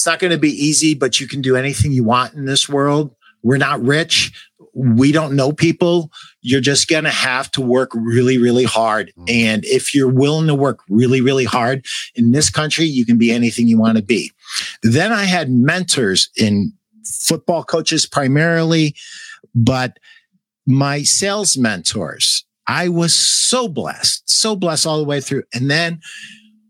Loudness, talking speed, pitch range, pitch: -15 LUFS, 175 wpm, 125-165 Hz, 140 Hz